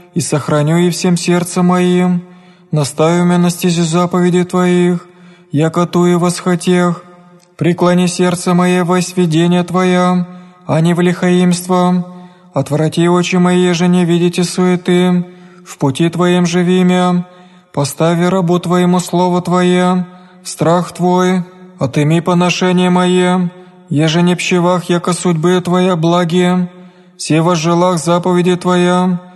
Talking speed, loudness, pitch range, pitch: 125 wpm, -13 LUFS, 175-180 Hz, 180 Hz